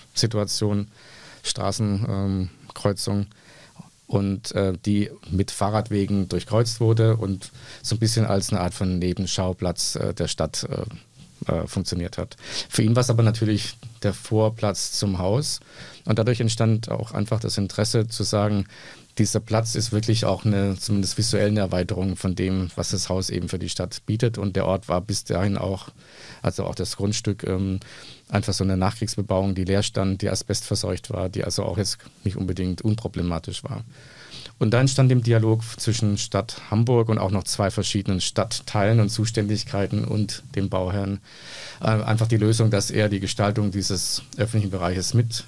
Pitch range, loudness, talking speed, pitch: 95-110 Hz, -24 LUFS, 165 wpm, 105 Hz